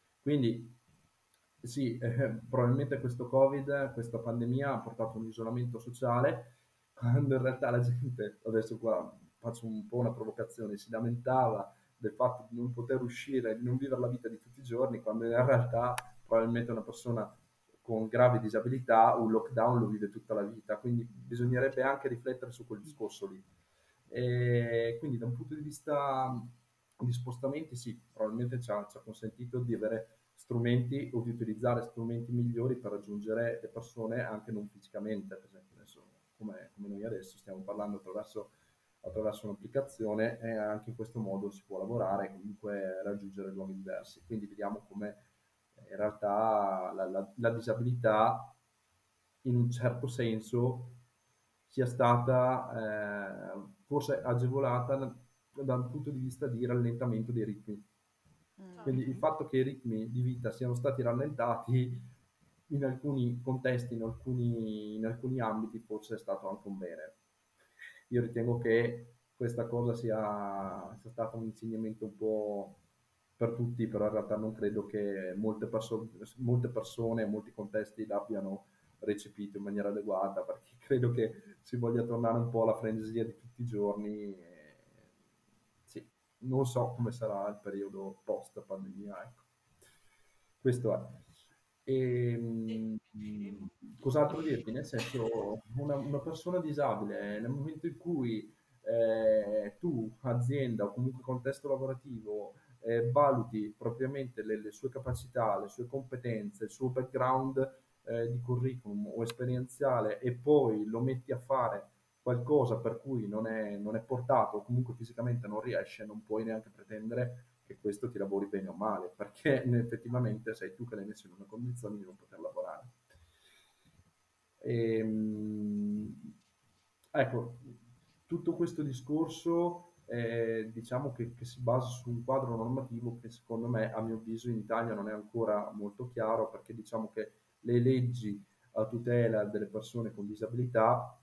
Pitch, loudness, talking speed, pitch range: 115 Hz, -35 LUFS, 150 wpm, 110-125 Hz